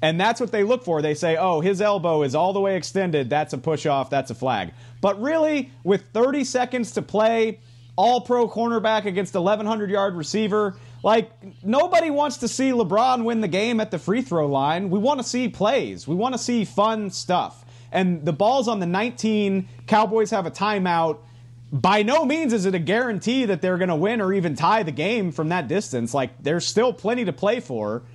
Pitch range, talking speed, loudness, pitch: 165-230 Hz, 210 wpm, -22 LUFS, 200 Hz